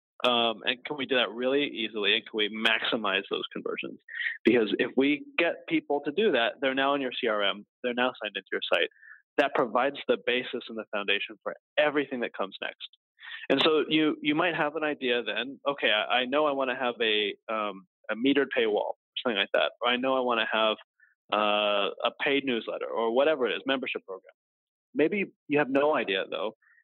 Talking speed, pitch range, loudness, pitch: 210 wpm, 115-150 Hz, -28 LUFS, 135 Hz